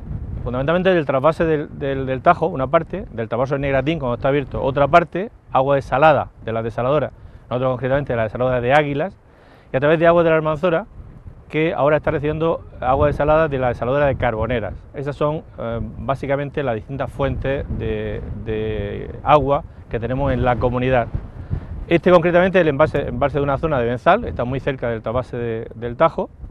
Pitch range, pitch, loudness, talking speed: 120-155 Hz, 135 Hz, -19 LUFS, 185 wpm